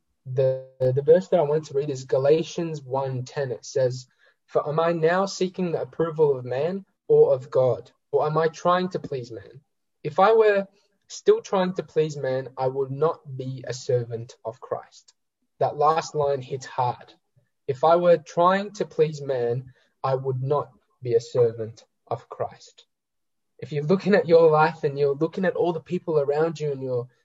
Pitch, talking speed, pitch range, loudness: 150 Hz, 185 wpm, 130-175 Hz, -24 LUFS